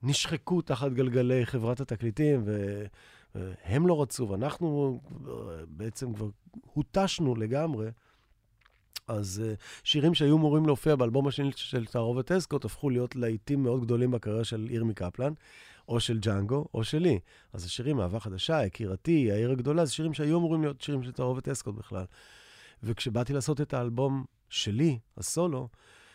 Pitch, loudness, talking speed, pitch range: 125 Hz, -30 LUFS, 140 wpm, 110-145 Hz